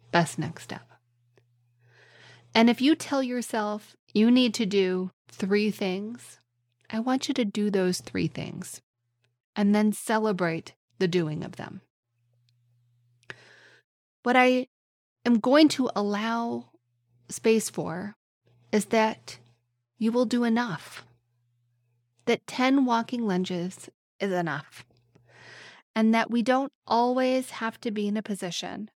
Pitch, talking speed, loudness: 190 Hz, 120 wpm, -26 LUFS